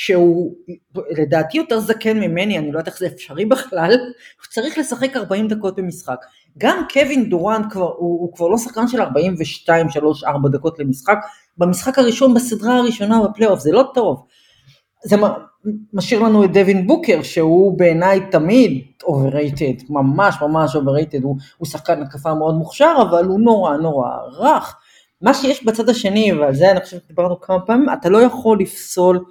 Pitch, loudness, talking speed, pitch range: 185 Hz, -16 LUFS, 165 wpm, 160-225 Hz